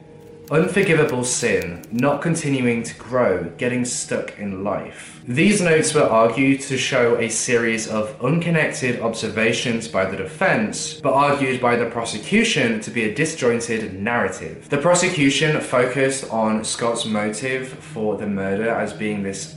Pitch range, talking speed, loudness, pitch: 115-150 Hz, 140 wpm, -20 LUFS, 125 Hz